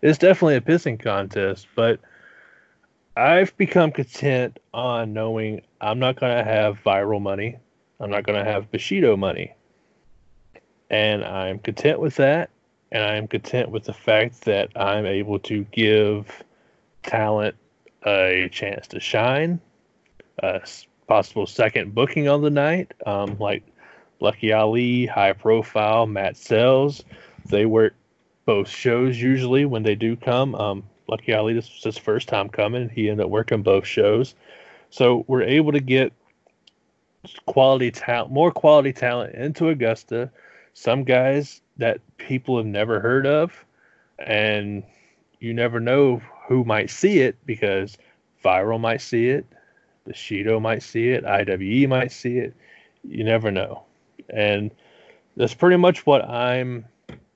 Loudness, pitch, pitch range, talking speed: -21 LUFS, 115 Hz, 105-130 Hz, 140 wpm